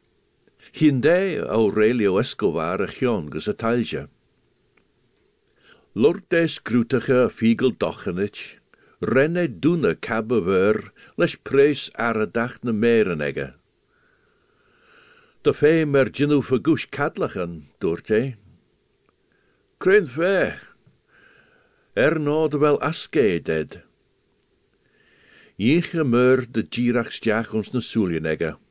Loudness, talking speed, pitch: -22 LUFS, 65 wpm, 150 Hz